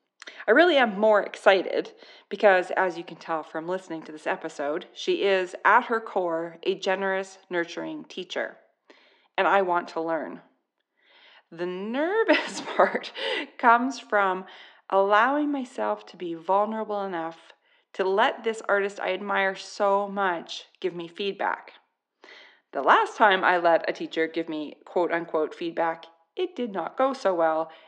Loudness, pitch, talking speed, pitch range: -25 LUFS, 190 Hz, 150 wpm, 170-220 Hz